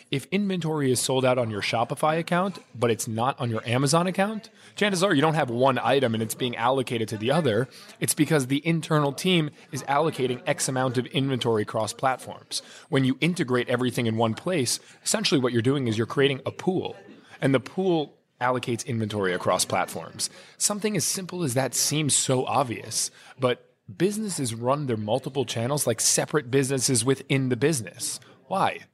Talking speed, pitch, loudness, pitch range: 180 wpm, 135 Hz, -25 LUFS, 120-155 Hz